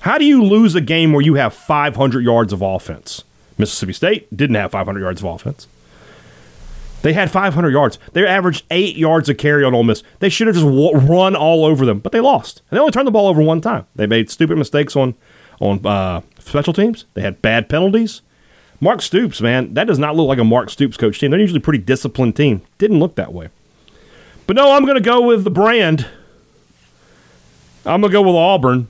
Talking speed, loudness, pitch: 220 wpm, -14 LUFS, 145 Hz